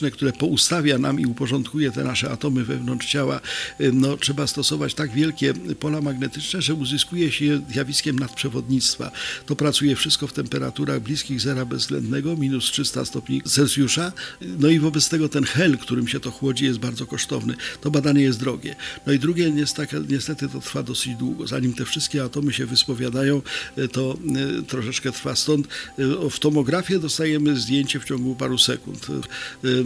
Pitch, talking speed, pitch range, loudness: 140 Hz, 160 wpm, 130-150 Hz, -22 LUFS